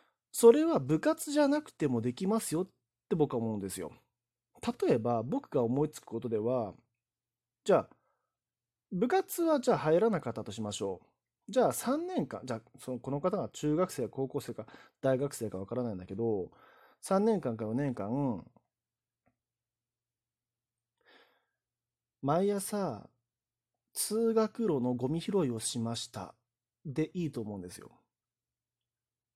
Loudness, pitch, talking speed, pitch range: -32 LUFS, 125 Hz, 260 characters per minute, 120-175 Hz